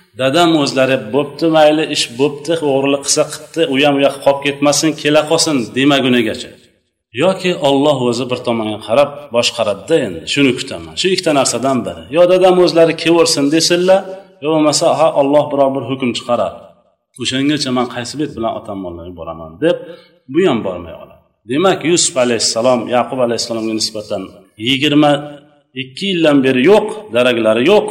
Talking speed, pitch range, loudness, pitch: 150 wpm, 125-160 Hz, -14 LUFS, 140 Hz